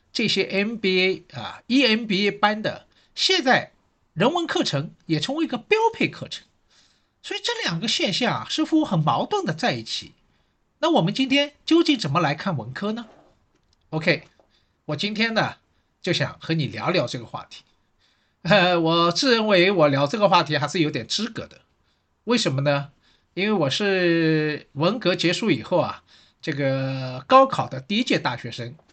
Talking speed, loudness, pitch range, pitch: 245 characters per minute, -22 LUFS, 150-235 Hz, 185 Hz